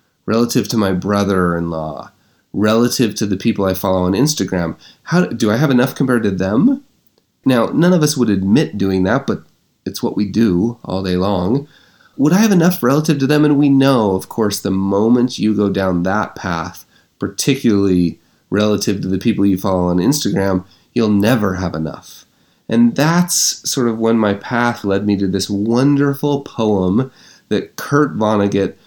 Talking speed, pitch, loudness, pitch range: 175 wpm, 105 Hz, -16 LUFS, 95-130 Hz